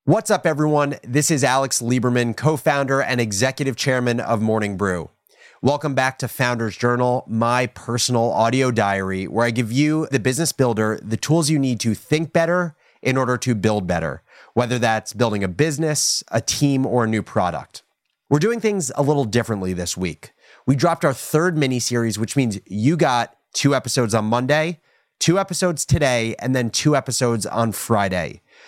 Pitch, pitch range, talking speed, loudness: 125 Hz, 115-145 Hz, 180 wpm, -20 LUFS